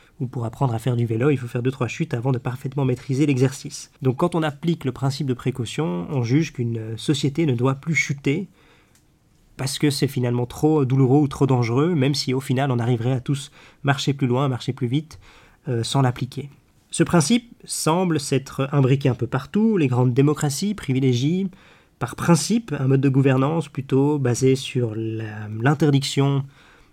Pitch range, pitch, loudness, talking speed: 125-150 Hz, 135 Hz, -22 LUFS, 185 wpm